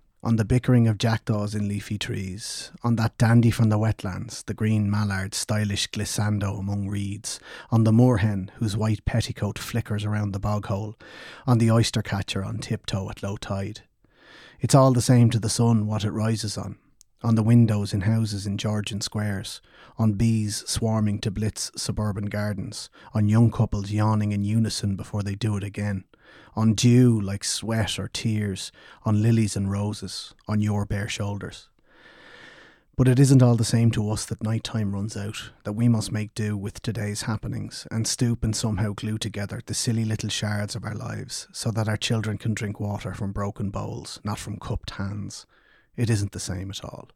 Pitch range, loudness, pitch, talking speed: 105-115 Hz, -25 LUFS, 110 Hz, 185 wpm